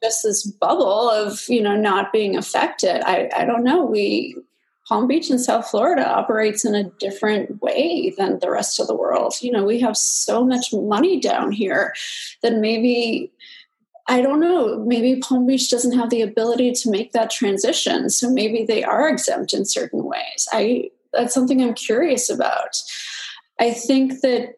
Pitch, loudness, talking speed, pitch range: 235 Hz, -19 LUFS, 175 wpm, 220-265 Hz